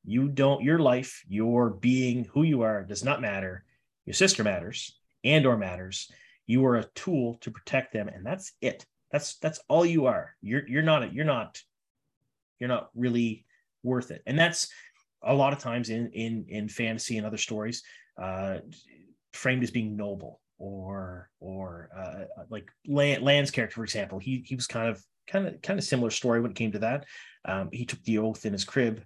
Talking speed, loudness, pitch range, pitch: 190 wpm, -28 LUFS, 105-135 Hz, 120 Hz